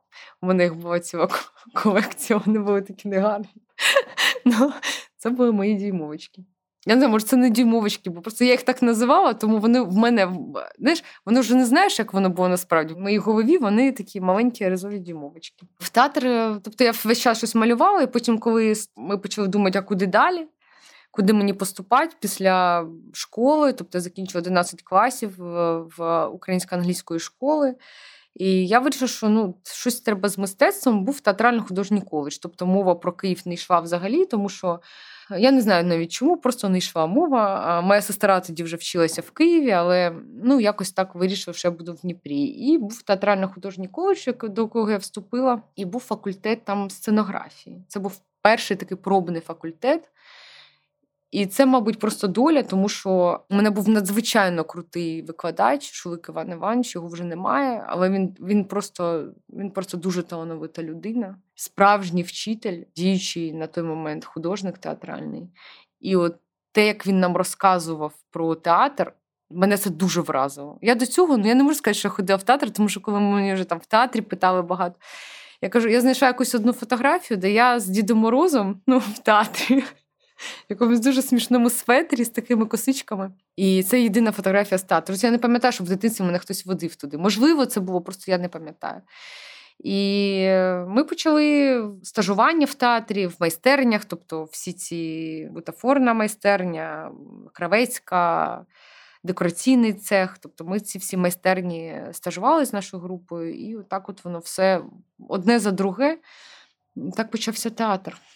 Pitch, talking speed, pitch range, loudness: 200 Hz, 165 wpm, 180-240 Hz, -22 LUFS